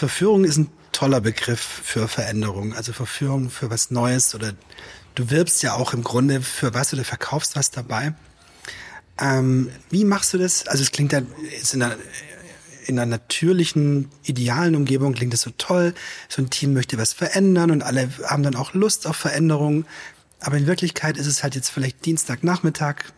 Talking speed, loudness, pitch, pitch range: 180 wpm, -21 LUFS, 140 Hz, 125-155 Hz